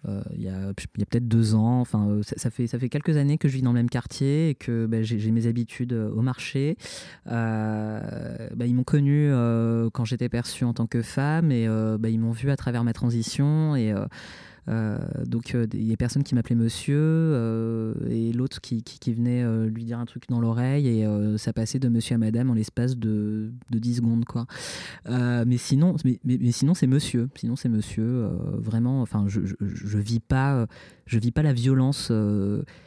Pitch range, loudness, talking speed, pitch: 110-125 Hz, -25 LUFS, 225 wpm, 120 Hz